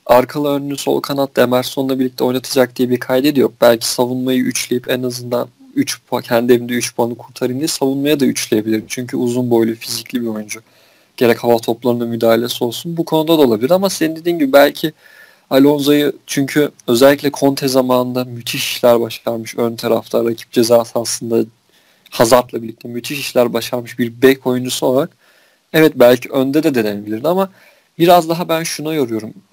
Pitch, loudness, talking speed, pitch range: 125 Hz, -15 LUFS, 160 wpm, 120-145 Hz